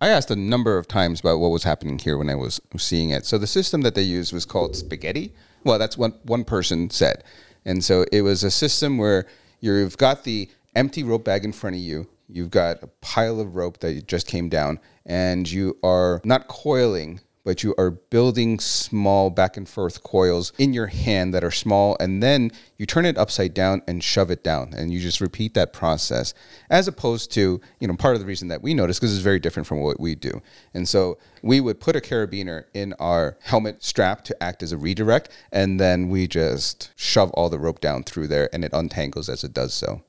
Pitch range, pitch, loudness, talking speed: 85-110 Hz, 95 Hz, -22 LUFS, 225 wpm